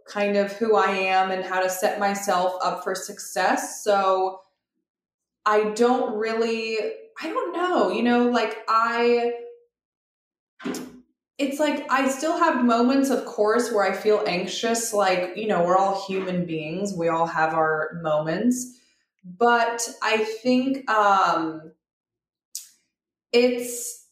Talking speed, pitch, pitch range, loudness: 130 wpm, 215 Hz, 190-245 Hz, -23 LUFS